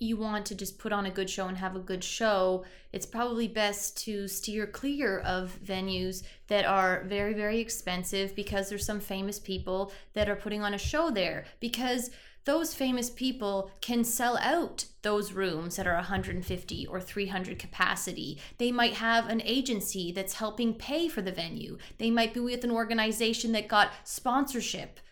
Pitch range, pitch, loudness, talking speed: 195-230 Hz, 210 Hz, -31 LUFS, 175 wpm